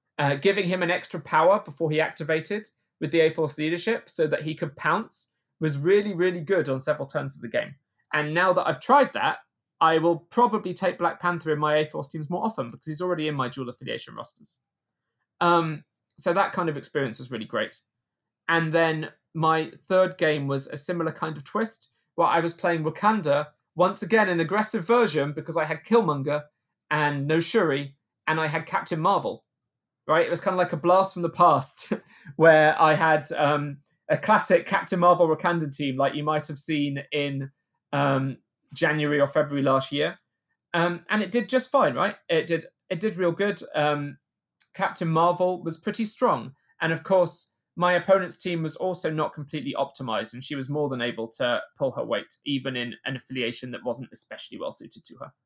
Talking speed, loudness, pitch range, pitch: 195 wpm, -24 LUFS, 145-180 Hz, 160 Hz